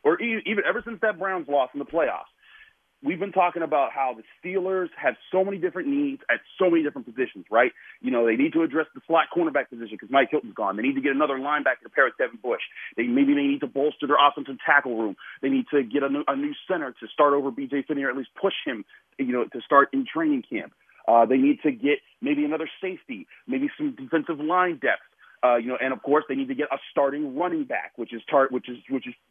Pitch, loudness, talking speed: 155 Hz, -25 LUFS, 250 wpm